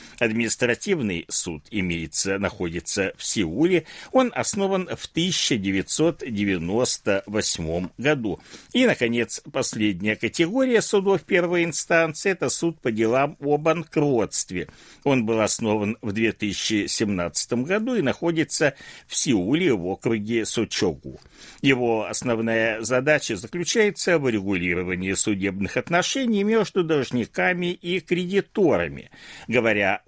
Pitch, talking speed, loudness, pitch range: 125 Hz, 100 wpm, -23 LUFS, 105-175 Hz